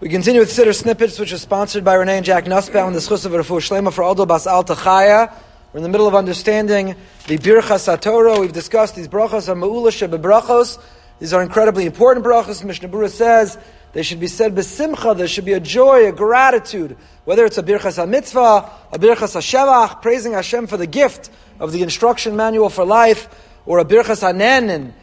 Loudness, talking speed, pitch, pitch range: -14 LUFS, 185 wpm, 210 Hz, 185-230 Hz